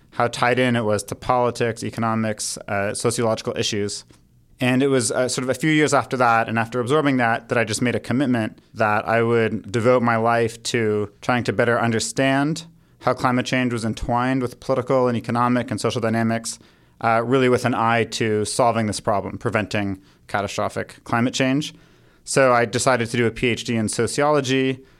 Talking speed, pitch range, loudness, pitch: 185 wpm, 110-125 Hz, -21 LUFS, 120 Hz